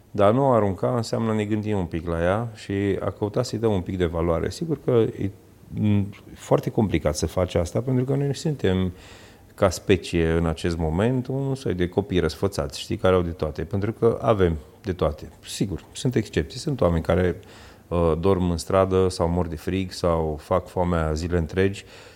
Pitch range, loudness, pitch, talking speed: 85-110 Hz, -24 LUFS, 95 Hz, 190 wpm